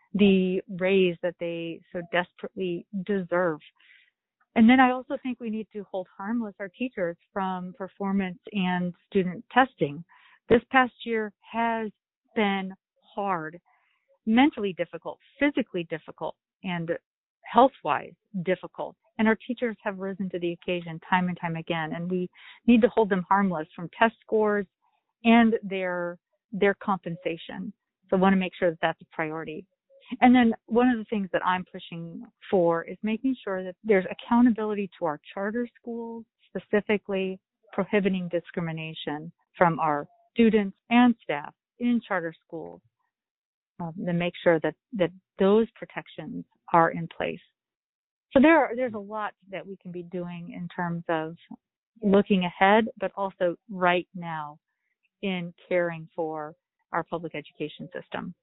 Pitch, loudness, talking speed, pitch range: 190 Hz, -26 LUFS, 145 wpm, 175-225 Hz